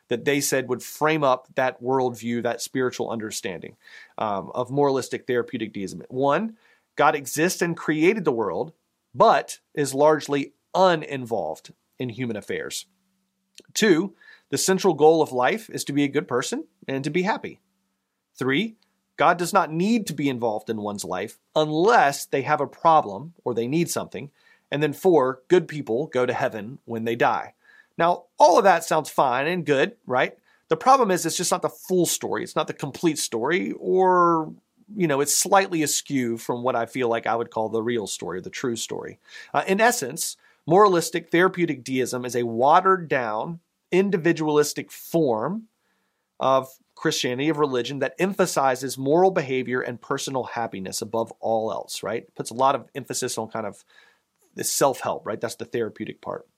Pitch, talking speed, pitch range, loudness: 145 Hz, 175 wpm, 125-170 Hz, -23 LUFS